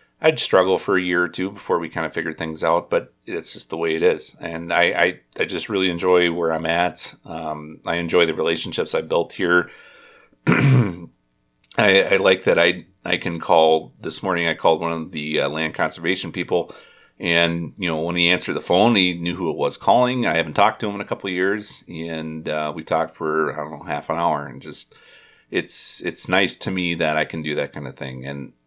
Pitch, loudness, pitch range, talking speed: 85 Hz, -21 LUFS, 80-90 Hz, 230 wpm